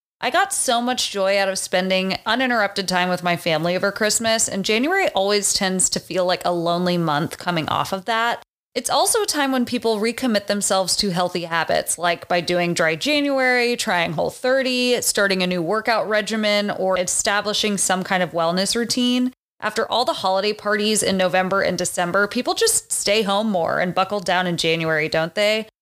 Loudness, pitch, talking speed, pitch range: -20 LUFS, 200 Hz, 190 wpm, 180-225 Hz